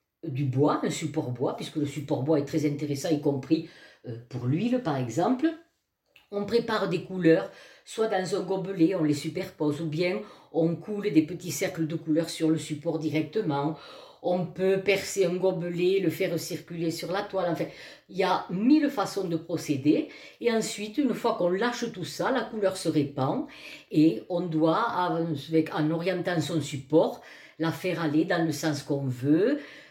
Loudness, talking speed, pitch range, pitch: -28 LUFS, 180 wpm, 155-190 Hz, 165 Hz